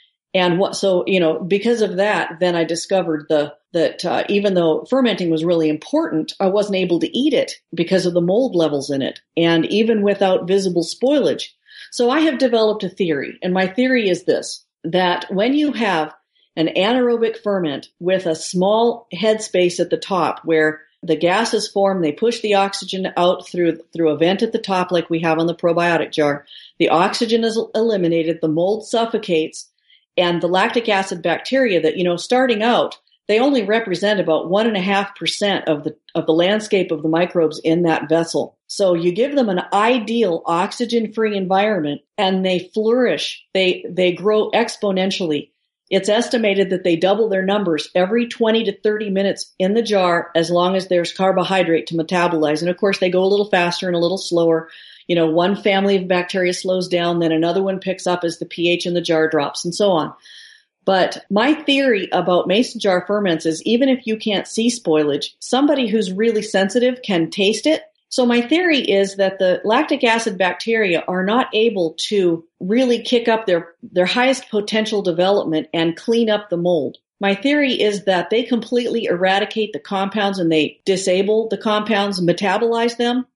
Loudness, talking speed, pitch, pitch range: -18 LUFS, 185 wpm, 190 Hz, 170-220 Hz